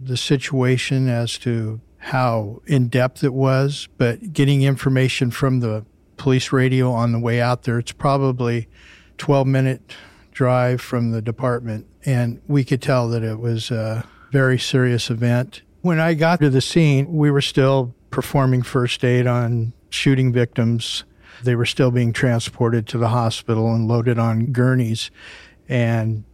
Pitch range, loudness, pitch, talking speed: 115-135 Hz, -19 LUFS, 125 Hz, 155 wpm